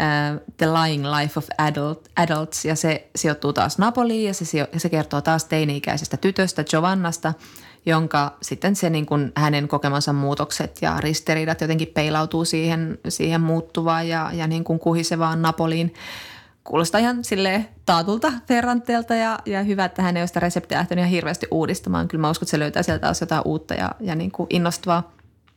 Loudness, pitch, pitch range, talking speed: -22 LUFS, 165 Hz, 155-180 Hz, 175 wpm